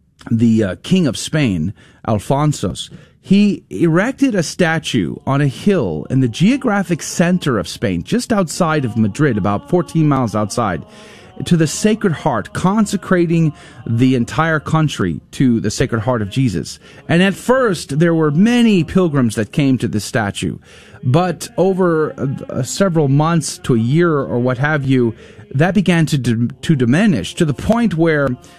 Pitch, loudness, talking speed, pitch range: 150 Hz, -16 LUFS, 155 wpm, 120-175 Hz